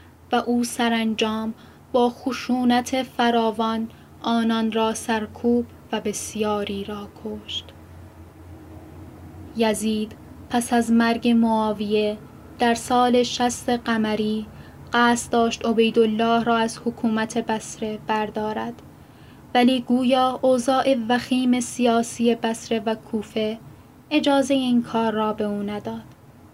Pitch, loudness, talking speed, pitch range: 230 Hz, -22 LUFS, 105 wpm, 215-245 Hz